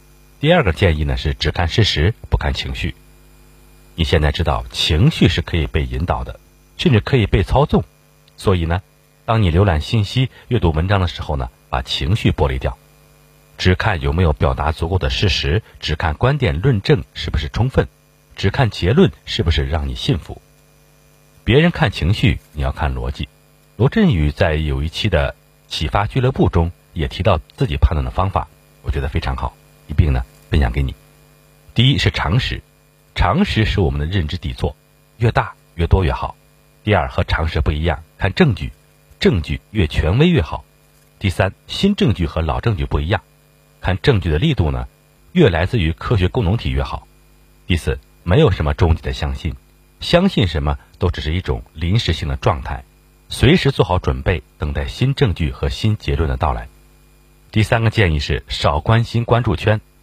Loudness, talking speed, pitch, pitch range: -18 LUFS, 265 characters per minute, 85 Hz, 75-100 Hz